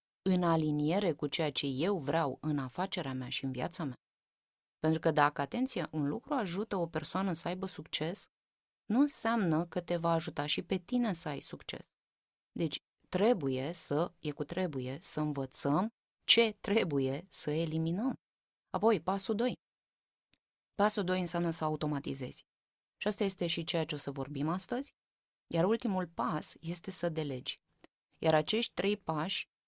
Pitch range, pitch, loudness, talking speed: 150-195 Hz, 165 Hz, -34 LUFS, 160 wpm